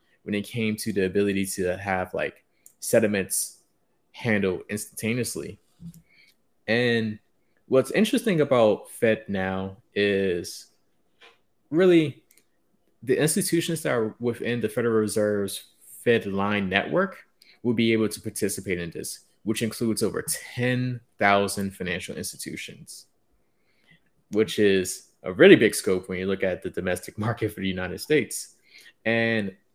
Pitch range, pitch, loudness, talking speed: 100-120 Hz, 110 Hz, -25 LUFS, 125 wpm